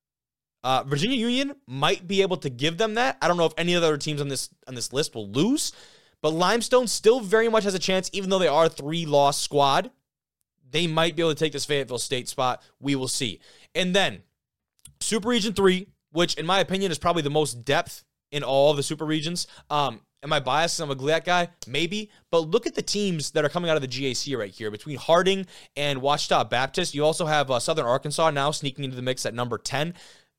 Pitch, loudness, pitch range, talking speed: 155 Hz, -24 LUFS, 140-185 Hz, 230 wpm